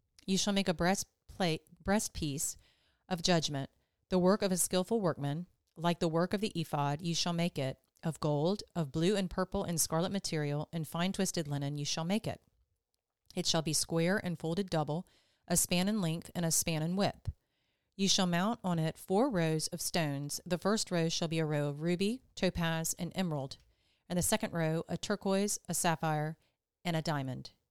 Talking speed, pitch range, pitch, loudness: 195 wpm, 160-190 Hz, 170 Hz, -33 LUFS